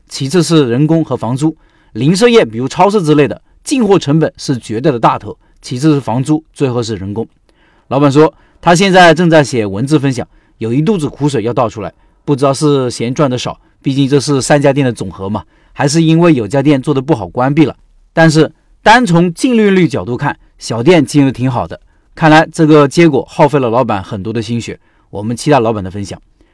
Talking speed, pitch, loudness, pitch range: 310 characters per minute, 140 Hz, -11 LUFS, 120-155 Hz